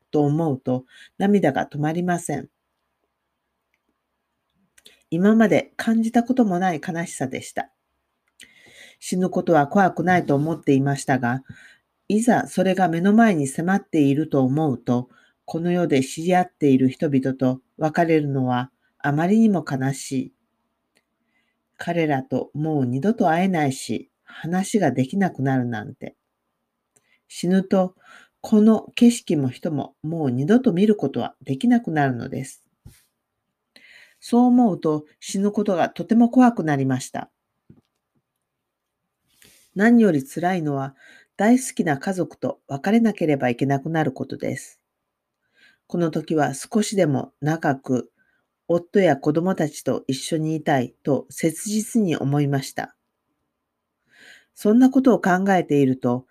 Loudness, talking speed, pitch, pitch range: -21 LUFS, 260 characters per minute, 160 Hz, 135-195 Hz